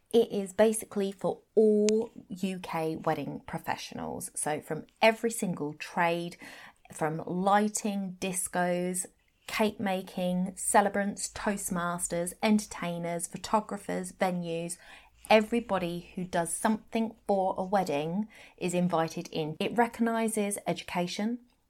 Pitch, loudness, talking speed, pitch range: 190 Hz, -30 LUFS, 100 wpm, 175-215 Hz